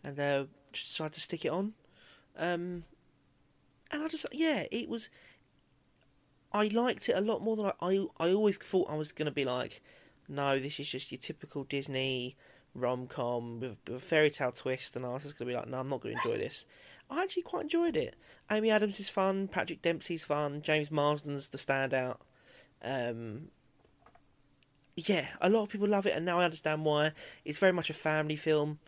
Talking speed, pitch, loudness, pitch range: 200 wpm, 155 Hz, -33 LUFS, 135-190 Hz